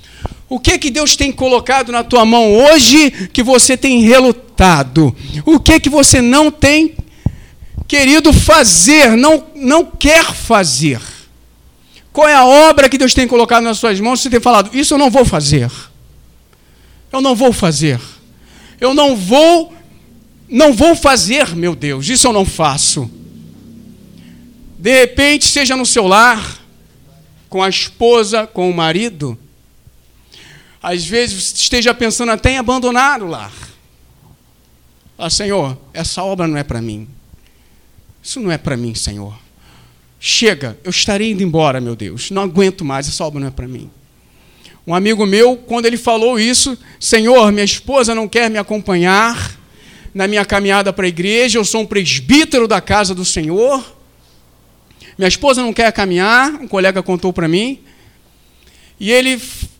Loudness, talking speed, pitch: -11 LUFS, 155 wpm, 210 Hz